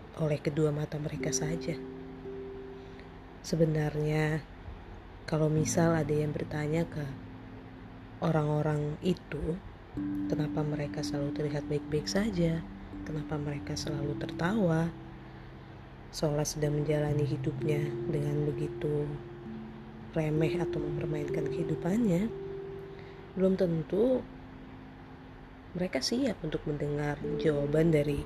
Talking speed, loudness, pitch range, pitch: 90 wpm, -32 LUFS, 130-160 Hz, 150 Hz